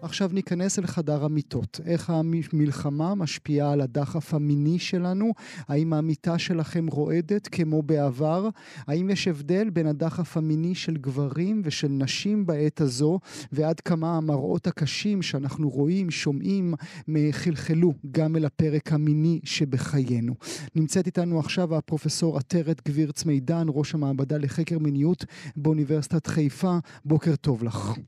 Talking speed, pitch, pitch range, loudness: 125 wpm, 155 Hz, 150-170 Hz, -26 LUFS